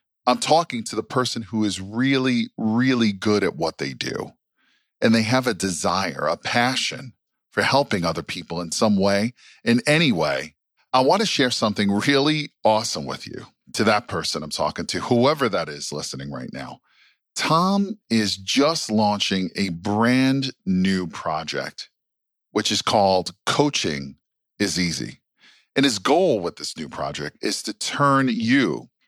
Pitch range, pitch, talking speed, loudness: 100-135 Hz, 115 Hz, 160 wpm, -22 LUFS